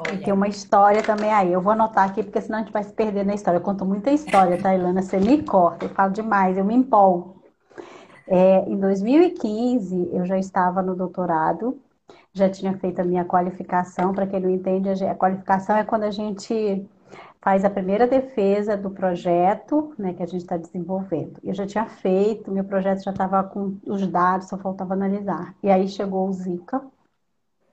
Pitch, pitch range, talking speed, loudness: 195 Hz, 185-210 Hz, 195 wpm, -22 LUFS